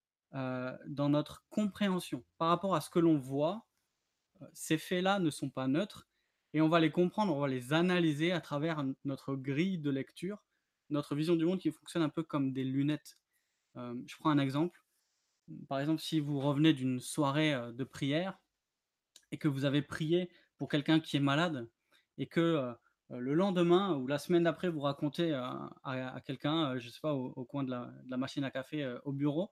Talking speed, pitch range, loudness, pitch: 210 wpm, 135-165 Hz, -34 LUFS, 150 Hz